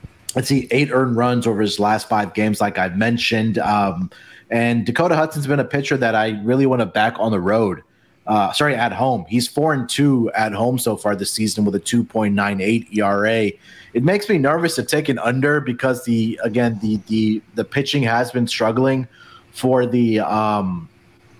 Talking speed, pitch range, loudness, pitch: 200 wpm, 110-130 Hz, -19 LUFS, 115 Hz